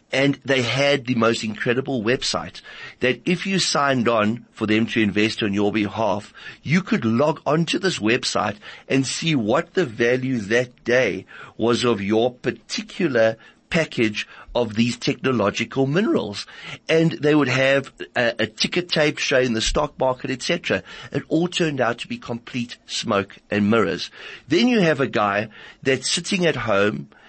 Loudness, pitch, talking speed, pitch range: -21 LUFS, 125 Hz, 160 wpm, 115-150 Hz